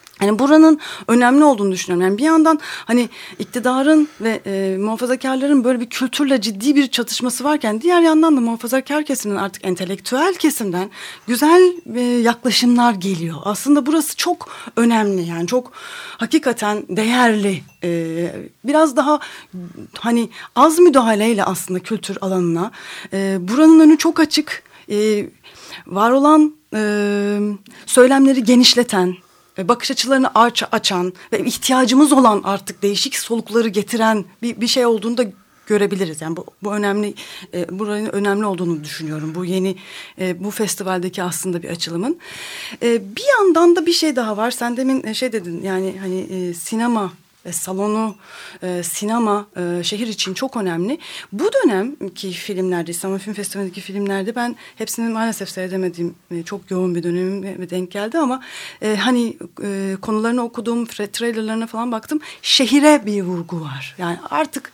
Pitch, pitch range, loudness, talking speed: 215 Hz, 190-255 Hz, -17 LUFS, 140 wpm